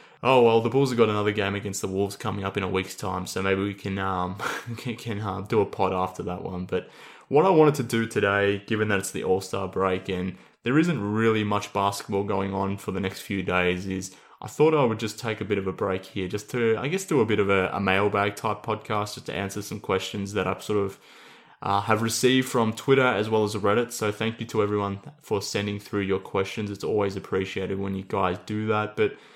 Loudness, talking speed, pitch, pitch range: -26 LUFS, 245 wpm, 100 Hz, 95-110 Hz